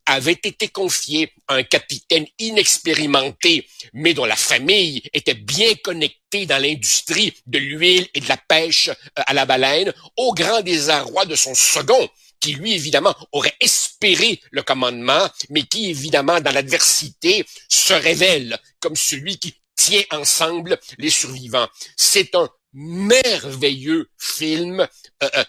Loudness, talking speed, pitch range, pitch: -17 LUFS, 135 wpm, 140-195 Hz, 160 Hz